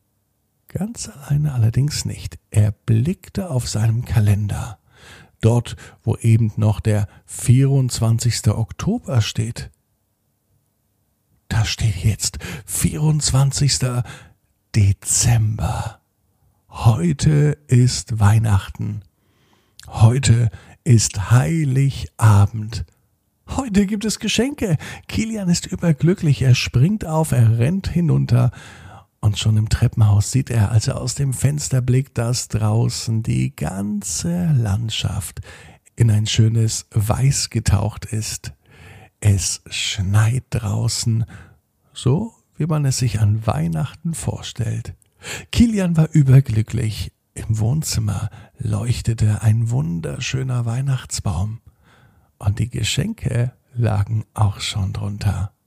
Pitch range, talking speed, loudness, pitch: 105-130 Hz, 100 wpm, -19 LUFS, 115 Hz